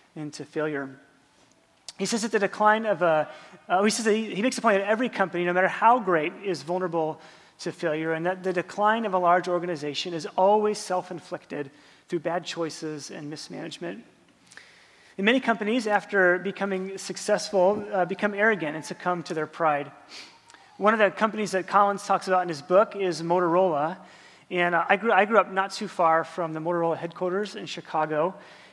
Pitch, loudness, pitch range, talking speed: 180 Hz, -25 LUFS, 165-200 Hz, 180 wpm